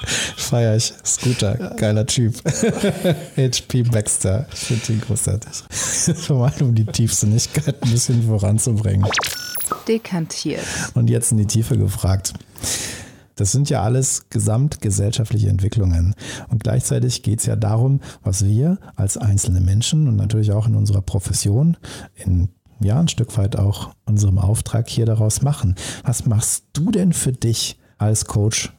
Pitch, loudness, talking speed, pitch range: 115 Hz, -19 LUFS, 140 wpm, 105-130 Hz